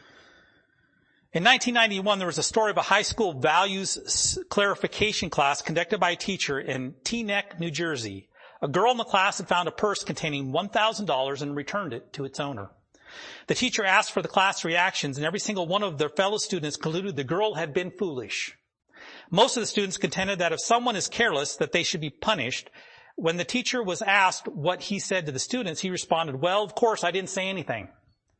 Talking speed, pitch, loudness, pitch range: 200 wpm, 190 Hz, -26 LUFS, 165-205 Hz